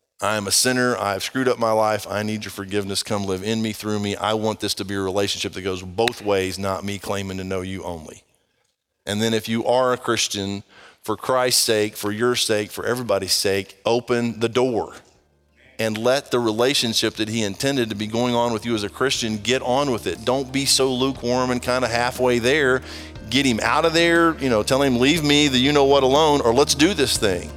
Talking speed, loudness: 235 wpm, -20 LUFS